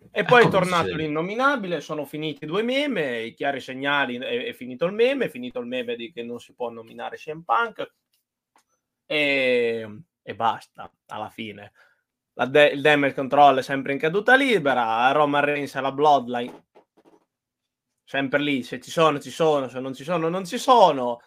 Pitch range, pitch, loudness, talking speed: 130-190 Hz, 145 Hz, -22 LUFS, 175 wpm